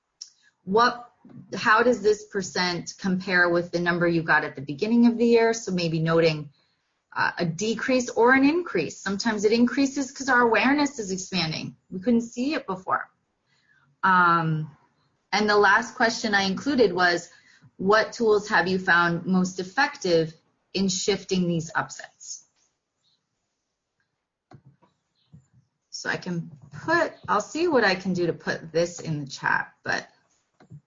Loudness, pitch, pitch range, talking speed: -23 LUFS, 190 Hz, 165-230 Hz, 145 wpm